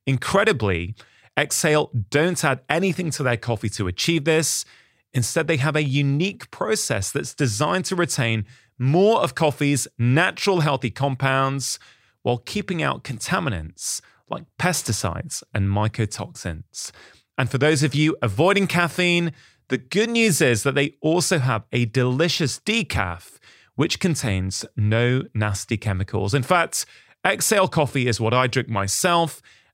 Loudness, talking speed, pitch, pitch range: -22 LUFS, 135 wpm, 140 Hz, 115-165 Hz